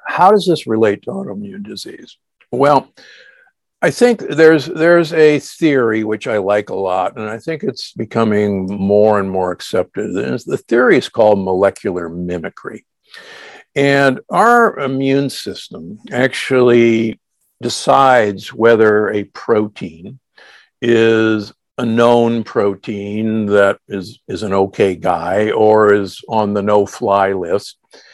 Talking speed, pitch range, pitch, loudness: 130 wpm, 105-140 Hz, 110 Hz, -14 LUFS